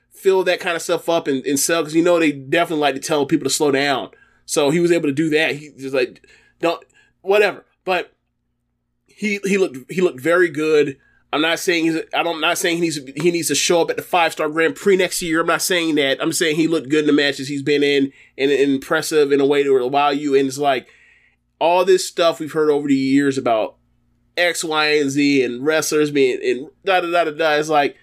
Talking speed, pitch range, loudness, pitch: 250 wpm, 140-170 Hz, -18 LUFS, 155 Hz